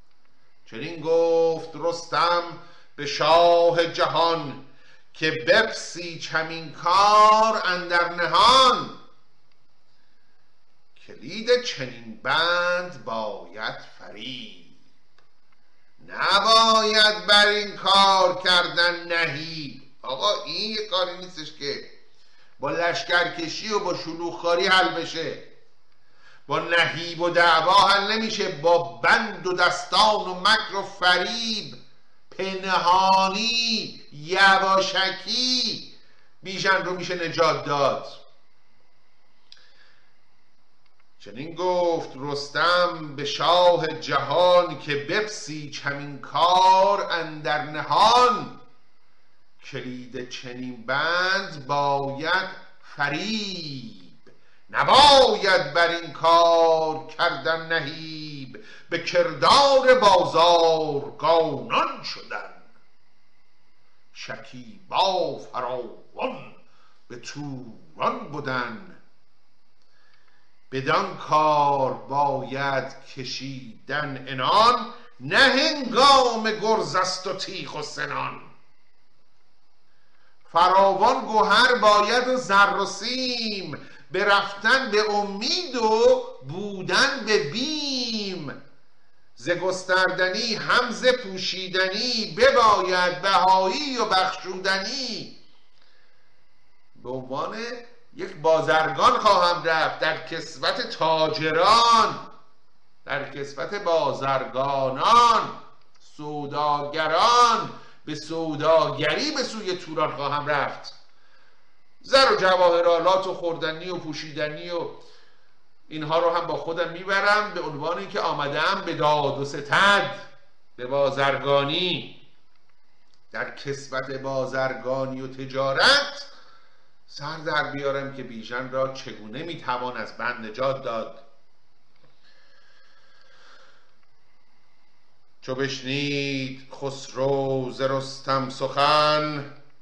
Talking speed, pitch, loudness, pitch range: 85 wpm, 170 Hz, -21 LUFS, 145-200 Hz